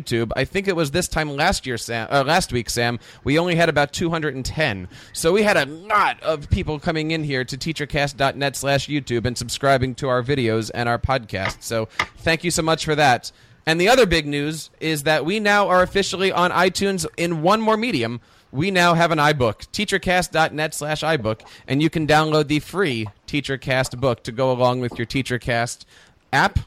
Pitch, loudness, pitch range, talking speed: 150 Hz, -20 LUFS, 125-165 Hz, 195 wpm